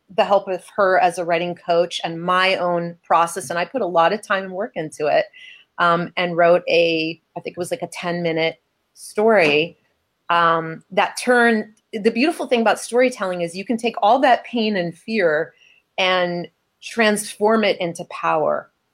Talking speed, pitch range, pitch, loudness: 185 wpm, 170-215 Hz, 180 Hz, -19 LUFS